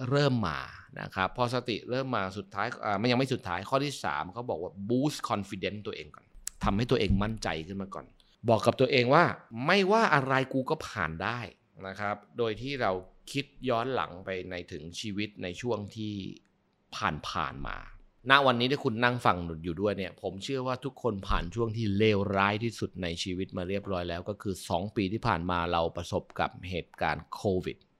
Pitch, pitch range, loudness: 105 Hz, 95-125 Hz, -30 LUFS